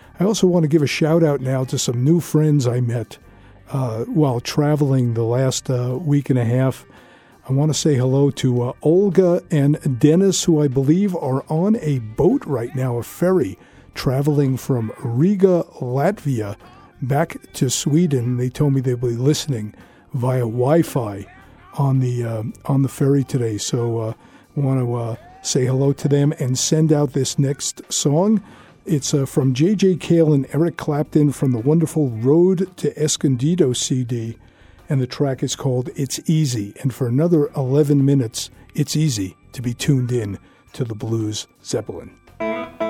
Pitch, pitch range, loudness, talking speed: 140 Hz, 125-155 Hz, -19 LUFS, 170 wpm